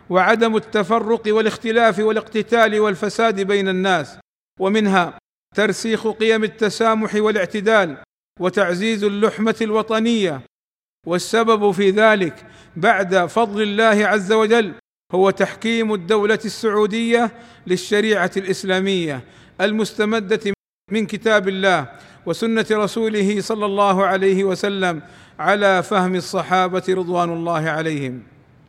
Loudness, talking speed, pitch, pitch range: -18 LUFS, 95 wpm, 210 Hz, 185-220 Hz